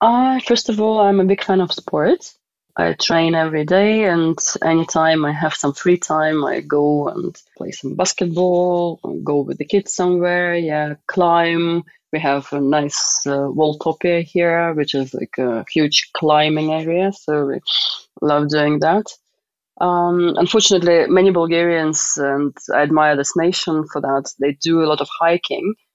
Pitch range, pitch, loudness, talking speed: 150-180 Hz, 165 Hz, -17 LUFS, 165 wpm